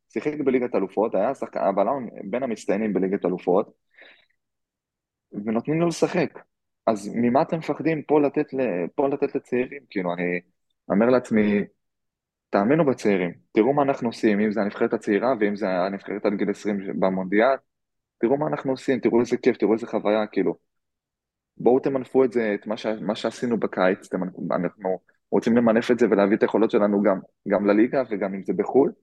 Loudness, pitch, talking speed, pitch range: -23 LUFS, 115 Hz, 165 wpm, 100-135 Hz